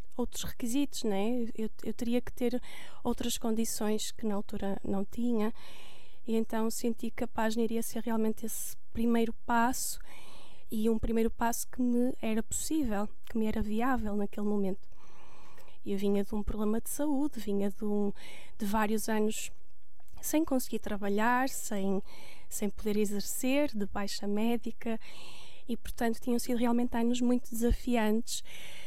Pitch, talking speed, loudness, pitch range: 225 Hz, 150 wpm, -33 LUFS, 210-240 Hz